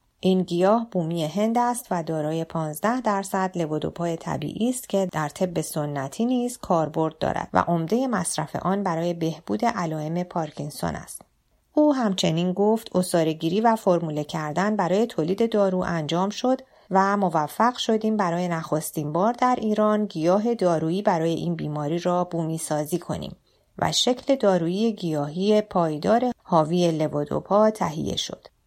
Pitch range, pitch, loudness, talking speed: 160-215 Hz, 180 Hz, -24 LUFS, 140 wpm